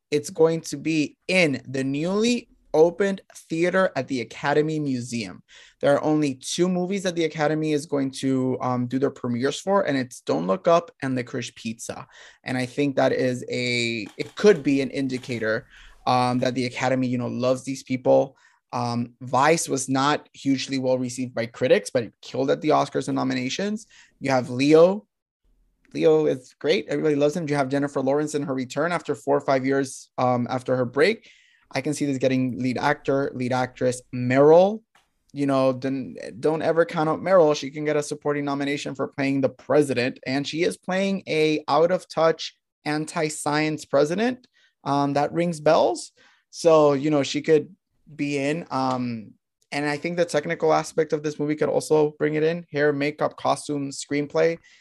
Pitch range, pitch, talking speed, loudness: 130-155 Hz, 145 Hz, 185 wpm, -23 LUFS